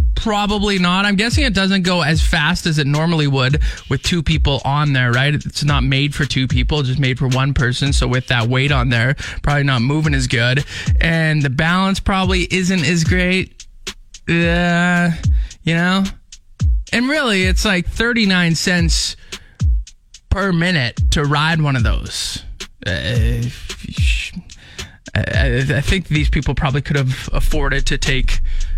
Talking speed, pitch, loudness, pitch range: 160 wpm, 145 Hz, -17 LUFS, 130-175 Hz